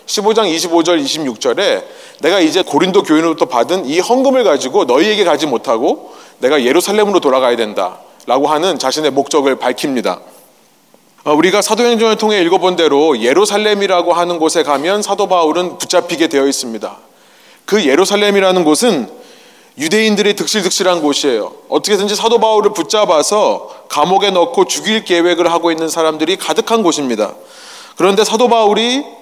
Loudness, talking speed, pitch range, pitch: -12 LUFS, 365 characters per minute, 170-230 Hz, 200 Hz